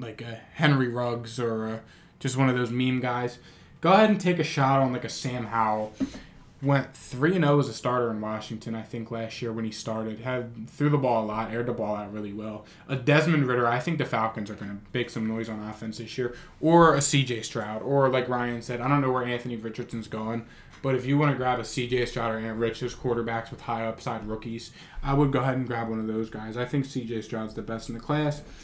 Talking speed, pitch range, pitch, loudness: 245 wpm, 110-135 Hz, 120 Hz, -27 LUFS